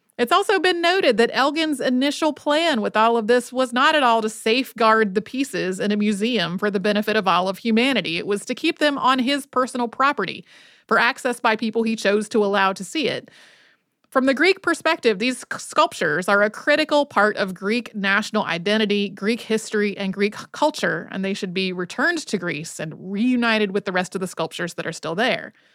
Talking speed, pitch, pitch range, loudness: 205 wpm, 225 Hz, 205-265 Hz, -21 LUFS